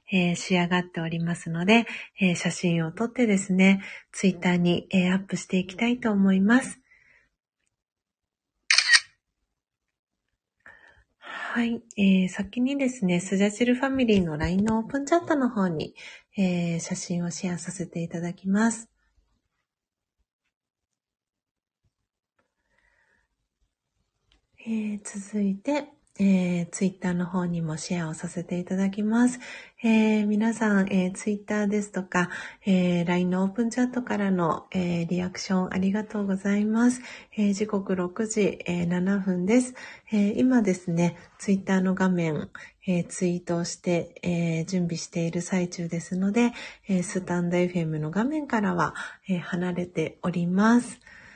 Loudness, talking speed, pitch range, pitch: -26 LUFS, 295 characters per minute, 175-215 Hz, 190 Hz